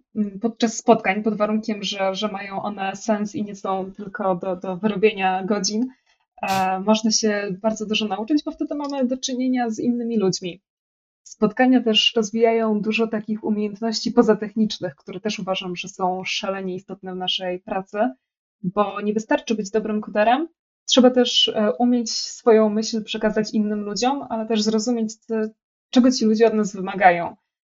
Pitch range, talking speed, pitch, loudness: 195-230 Hz, 160 wpm, 215 Hz, -21 LUFS